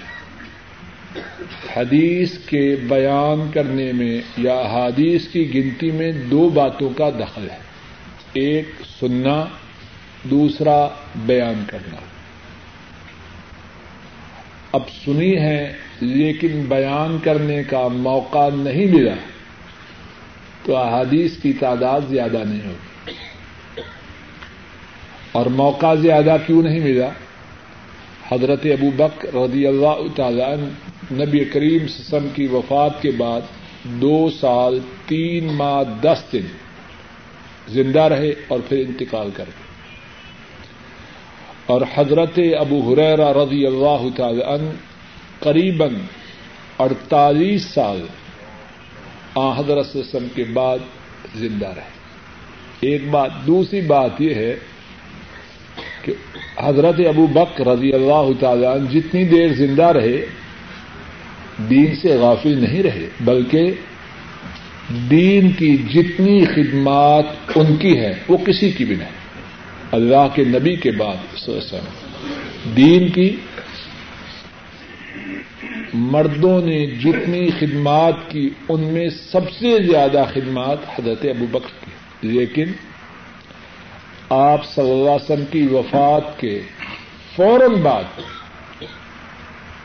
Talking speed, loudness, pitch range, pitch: 105 wpm, -17 LUFS, 125-155 Hz, 140 Hz